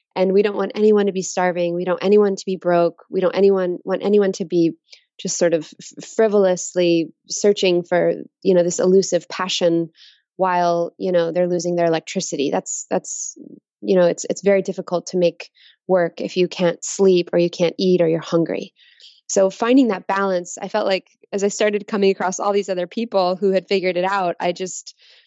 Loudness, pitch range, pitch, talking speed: -19 LUFS, 175-195 Hz, 185 Hz, 200 wpm